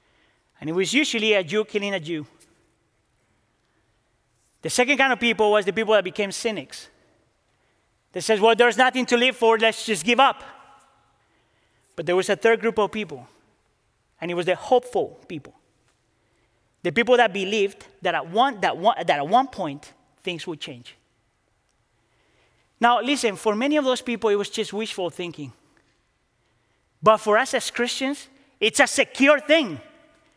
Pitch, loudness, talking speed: 210 Hz, -21 LUFS, 165 wpm